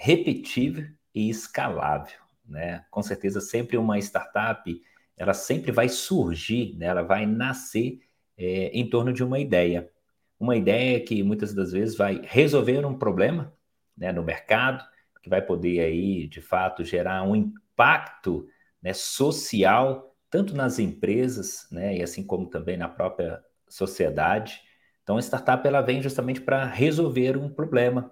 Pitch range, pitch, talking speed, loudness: 95-130 Hz, 115 Hz, 145 wpm, -25 LUFS